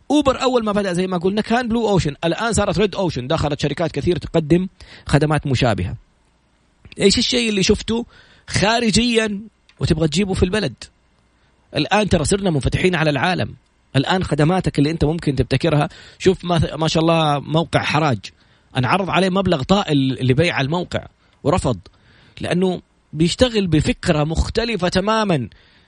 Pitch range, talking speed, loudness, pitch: 135-195 Hz, 140 wpm, -19 LUFS, 165 Hz